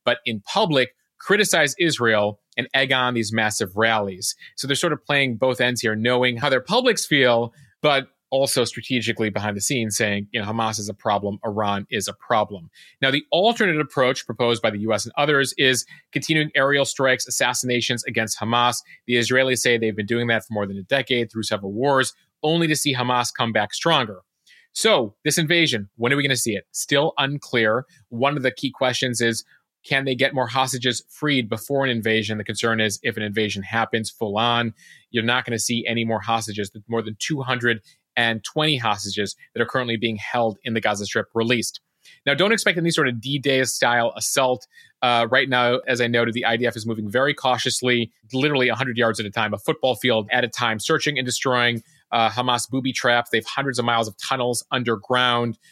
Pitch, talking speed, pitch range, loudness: 120 Hz, 200 wpm, 115-135 Hz, -21 LUFS